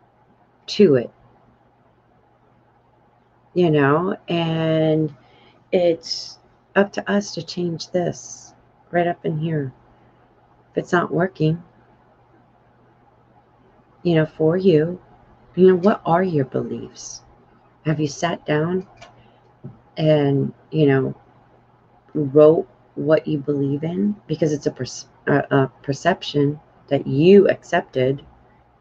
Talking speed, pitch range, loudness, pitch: 110 wpm, 130-170 Hz, -20 LUFS, 155 Hz